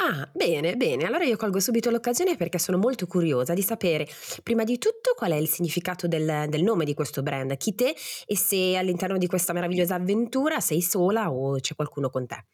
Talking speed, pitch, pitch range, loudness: 205 wpm, 180 Hz, 155-220 Hz, -25 LUFS